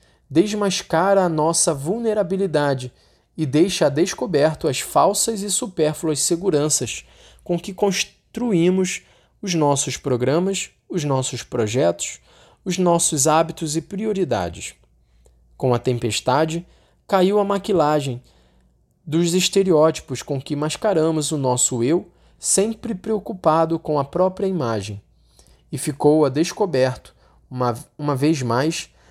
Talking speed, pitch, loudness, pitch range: 115 wpm, 155 Hz, -20 LUFS, 130-185 Hz